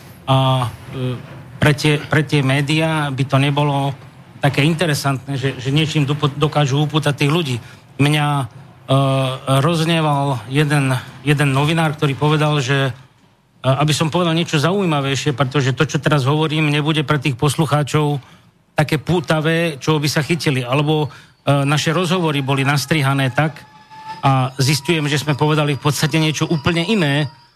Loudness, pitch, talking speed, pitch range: -17 LUFS, 150 Hz, 145 wpm, 135-155 Hz